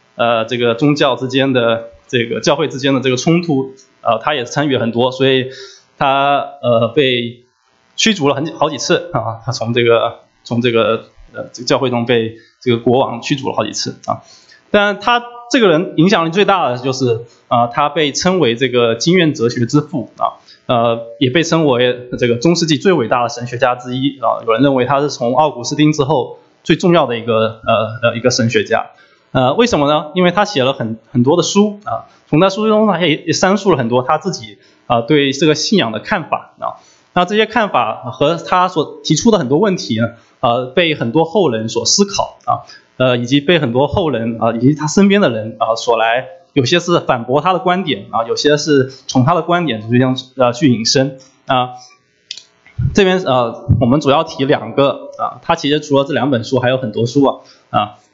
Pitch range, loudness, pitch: 120-165 Hz, -14 LUFS, 135 Hz